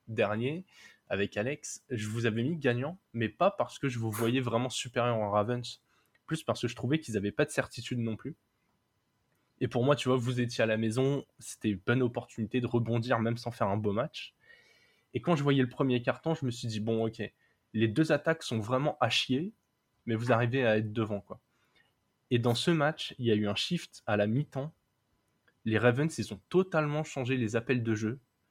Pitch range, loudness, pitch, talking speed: 110-135 Hz, -31 LUFS, 120 Hz, 215 wpm